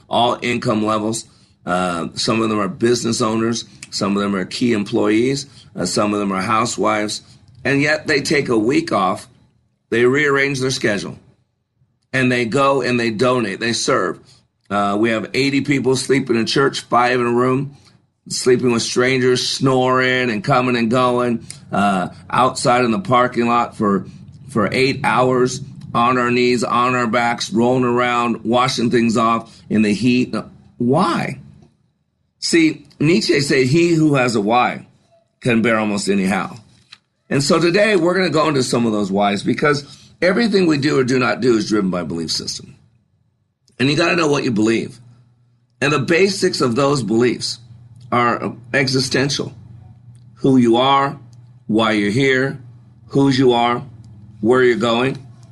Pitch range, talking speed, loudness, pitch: 115-135 Hz, 165 wpm, -17 LUFS, 120 Hz